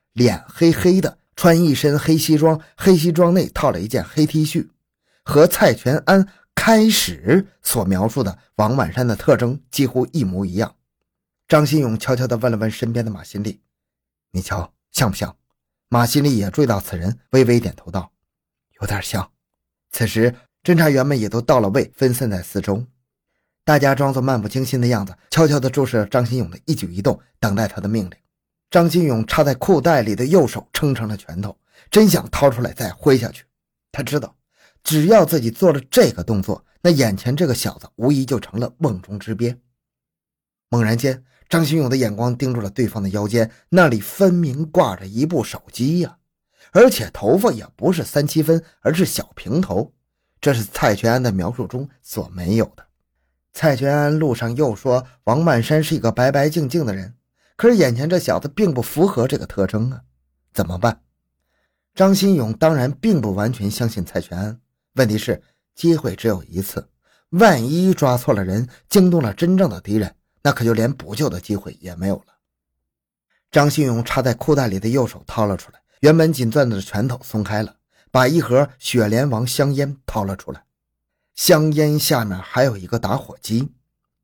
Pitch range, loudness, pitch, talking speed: 105-150 Hz, -18 LUFS, 125 Hz, 265 characters per minute